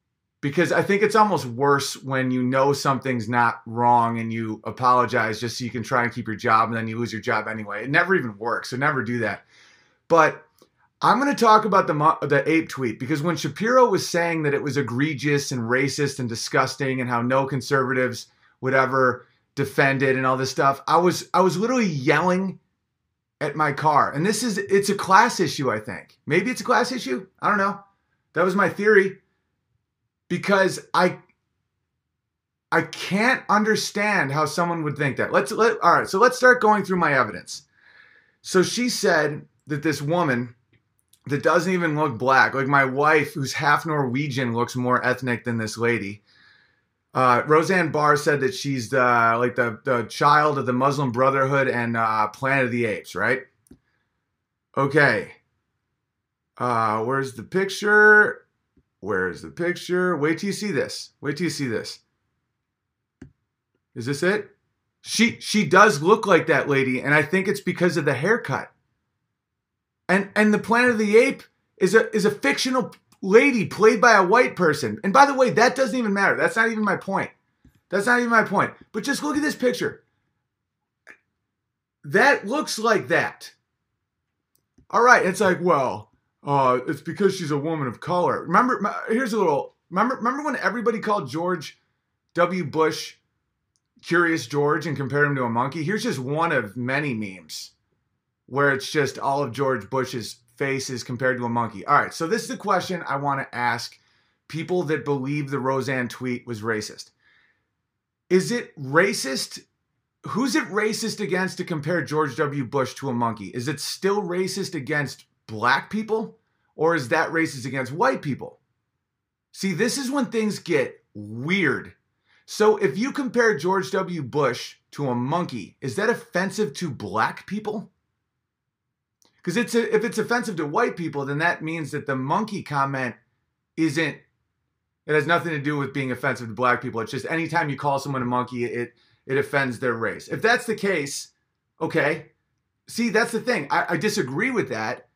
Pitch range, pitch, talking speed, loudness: 130-195 Hz, 150 Hz, 180 wpm, -22 LUFS